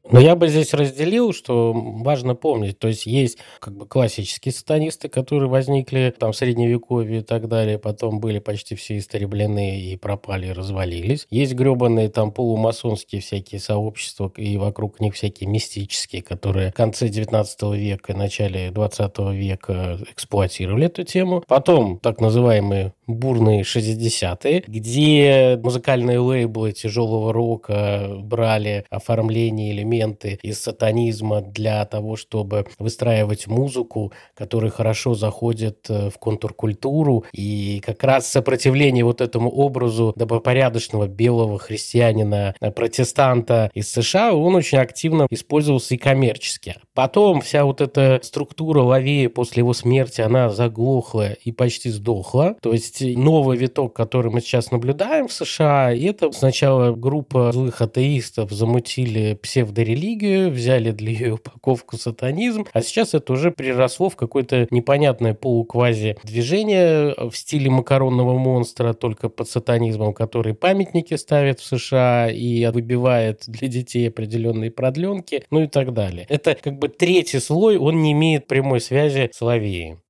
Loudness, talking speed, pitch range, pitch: -20 LUFS, 135 wpm, 110-135 Hz, 120 Hz